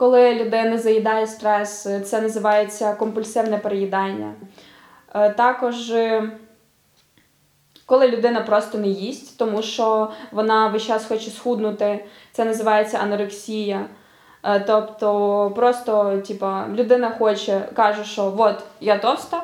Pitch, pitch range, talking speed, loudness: 220 Hz, 210-230 Hz, 105 wpm, -20 LUFS